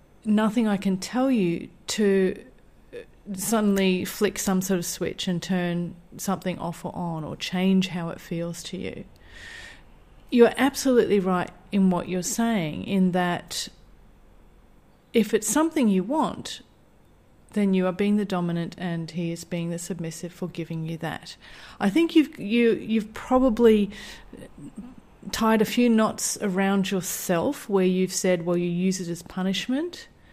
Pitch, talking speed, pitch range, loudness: 190 Hz, 150 wpm, 175-220 Hz, -25 LUFS